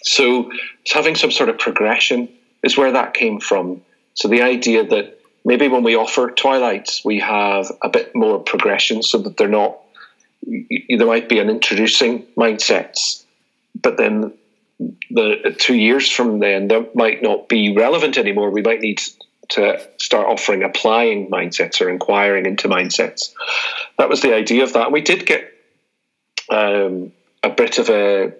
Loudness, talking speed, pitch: -16 LUFS, 165 wpm, 120 Hz